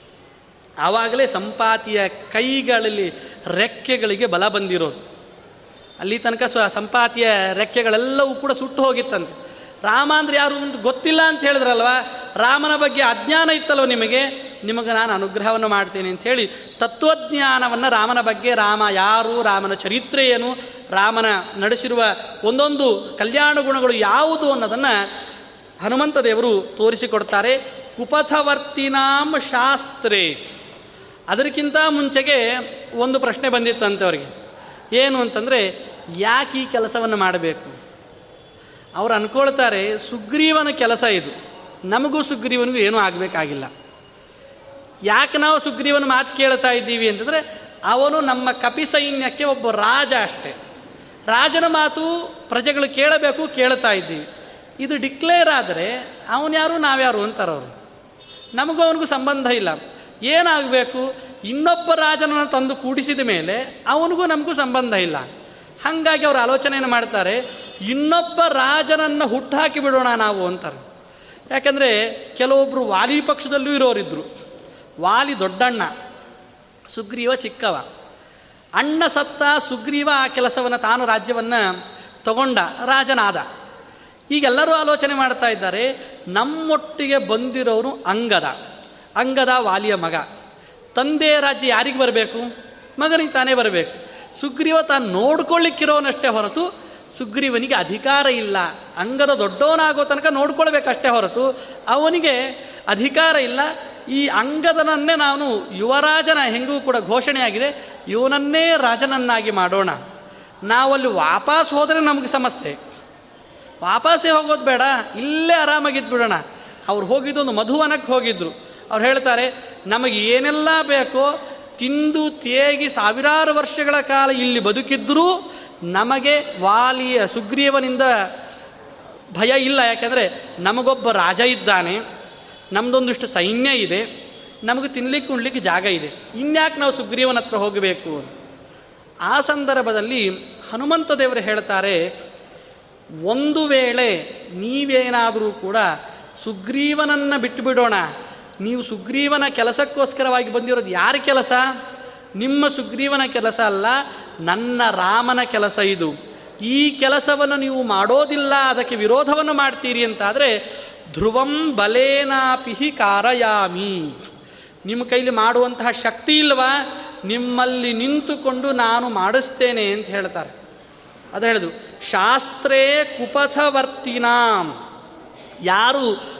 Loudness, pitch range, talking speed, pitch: -18 LUFS, 230-285 Hz, 95 wpm, 260 Hz